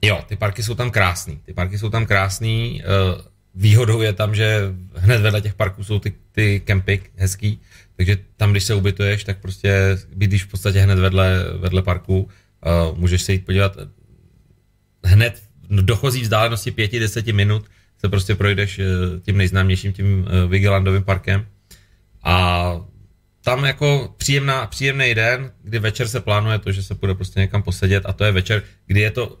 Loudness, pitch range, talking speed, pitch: -19 LUFS, 95-110 Hz, 160 wpm, 100 Hz